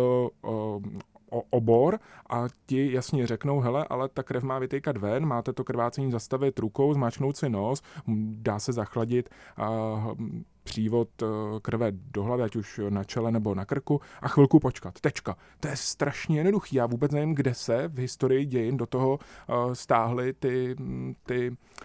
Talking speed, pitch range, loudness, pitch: 160 wpm, 110-135 Hz, -28 LUFS, 125 Hz